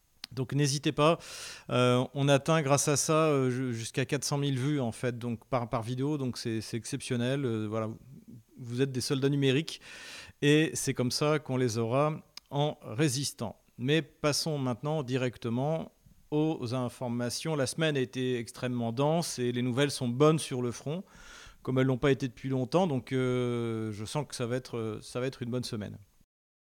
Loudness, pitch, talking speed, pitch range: -30 LUFS, 130 Hz, 180 wpm, 120-145 Hz